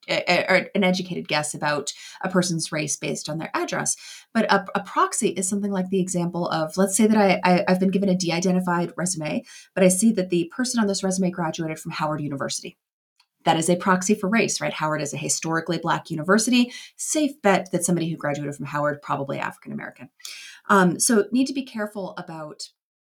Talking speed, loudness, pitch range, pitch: 200 wpm, -23 LUFS, 160-200 Hz, 185 Hz